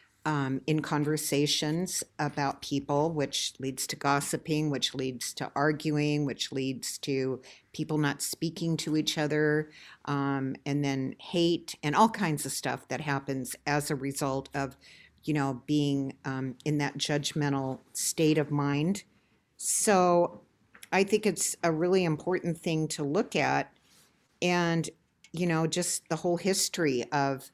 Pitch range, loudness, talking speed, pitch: 140-165 Hz, -29 LUFS, 145 wpm, 150 Hz